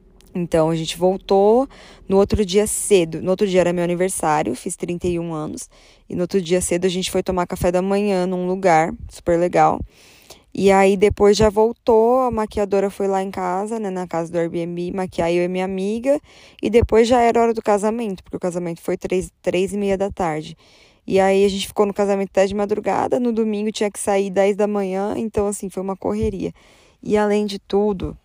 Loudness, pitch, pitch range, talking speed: -19 LUFS, 195 Hz, 180-210 Hz, 210 wpm